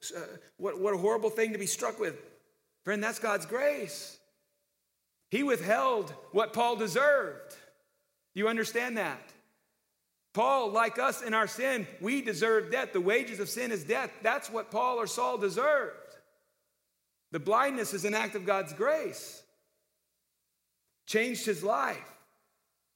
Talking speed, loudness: 145 wpm, -30 LUFS